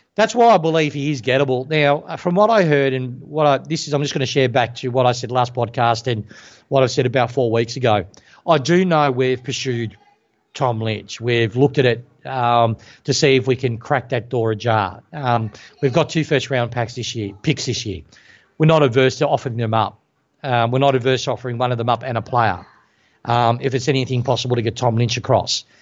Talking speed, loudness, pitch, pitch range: 230 wpm, -18 LUFS, 130 Hz, 120-140 Hz